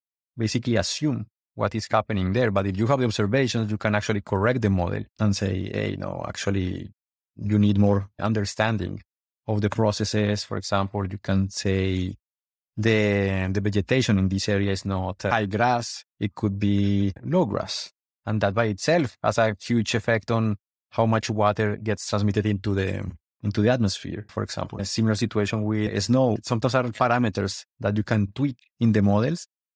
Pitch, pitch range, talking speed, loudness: 105 Hz, 100-110 Hz, 175 wpm, -24 LUFS